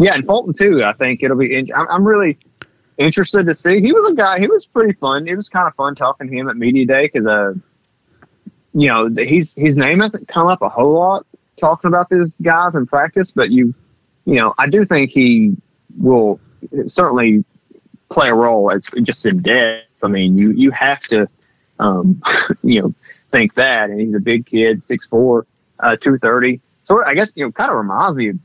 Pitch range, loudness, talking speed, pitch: 120-185 Hz, -14 LUFS, 205 wpm, 145 Hz